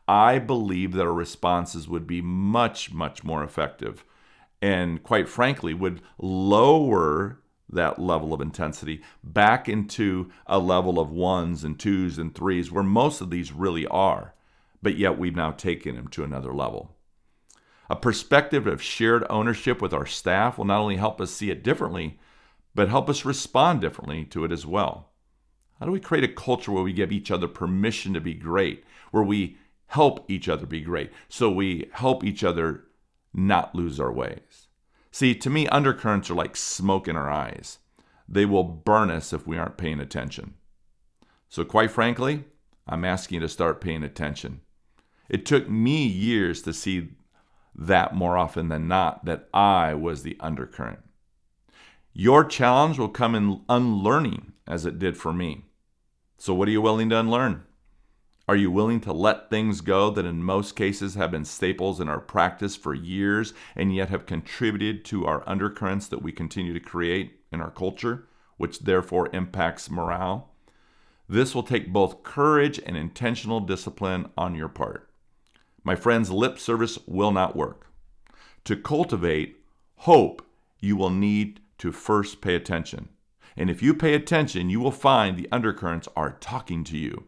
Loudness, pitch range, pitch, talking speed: -25 LUFS, 85-110 Hz, 95 Hz, 170 wpm